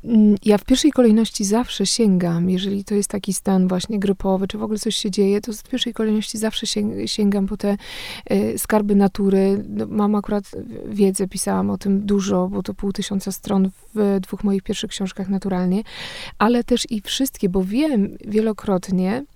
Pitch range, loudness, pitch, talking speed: 195-215 Hz, -20 LUFS, 205 Hz, 175 wpm